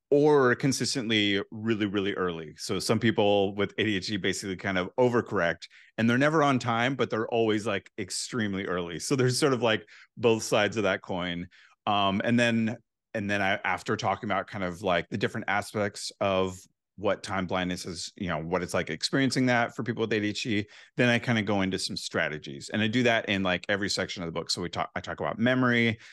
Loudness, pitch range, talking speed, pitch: -27 LUFS, 95-120 Hz, 210 wpm, 105 Hz